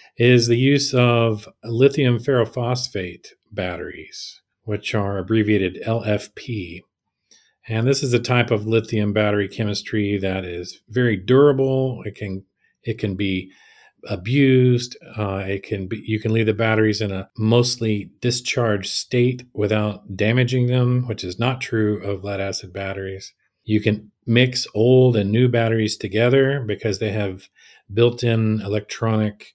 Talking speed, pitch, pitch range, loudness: 140 wpm, 110 Hz, 105-120 Hz, -20 LUFS